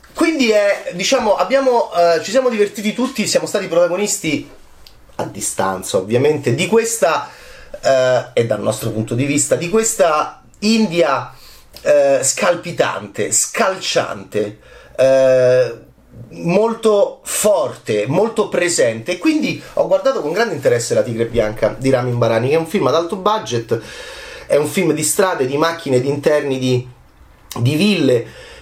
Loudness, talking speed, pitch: -16 LUFS, 140 wpm, 170 Hz